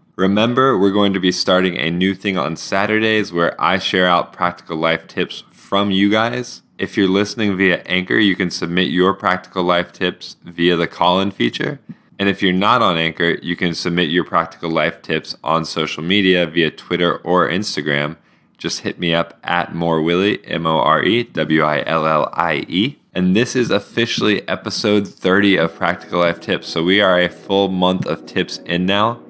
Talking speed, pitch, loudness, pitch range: 170 wpm, 90 Hz, -17 LUFS, 85-100 Hz